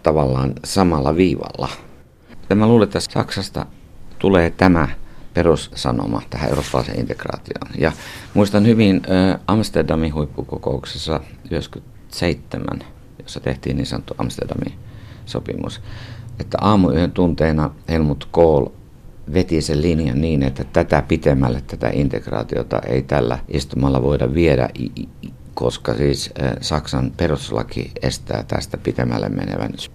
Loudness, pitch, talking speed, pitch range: -19 LUFS, 80 Hz, 110 wpm, 70-95 Hz